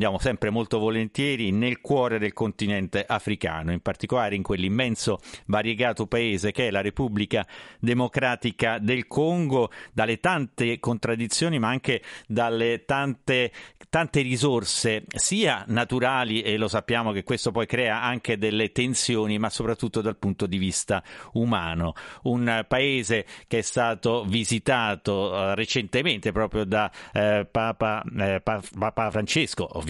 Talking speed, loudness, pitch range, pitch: 130 wpm, -25 LUFS, 105-125 Hz, 115 Hz